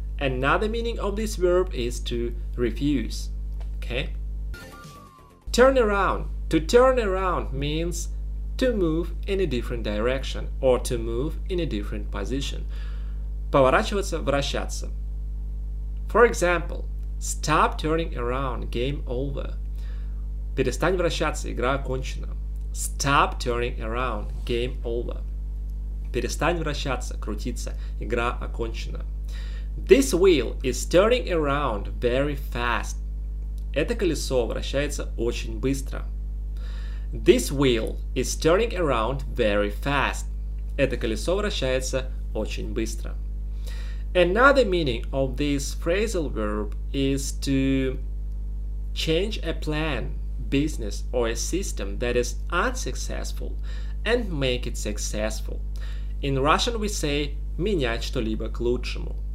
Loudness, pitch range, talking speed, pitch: -26 LUFS, 115-160 Hz, 100 wpm, 130 Hz